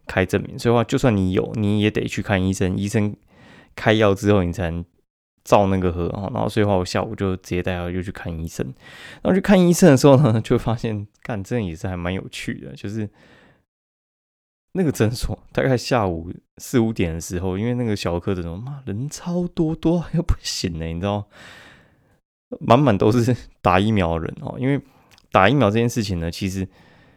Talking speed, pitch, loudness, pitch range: 290 characters per minute, 105 Hz, -21 LUFS, 95-120 Hz